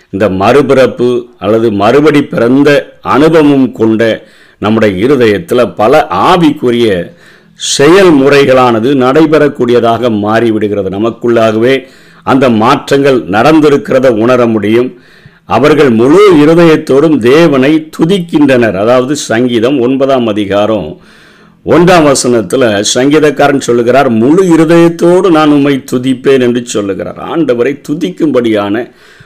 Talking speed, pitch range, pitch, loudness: 85 wpm, 115-145 Hz, 125 Hz, -7 LUFS